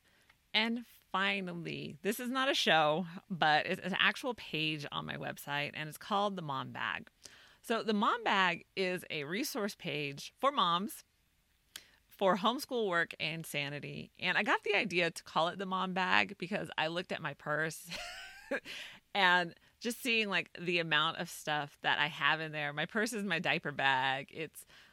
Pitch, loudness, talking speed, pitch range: 180 Hz, -33 LUFS, 175 wpm, 155-210 Hz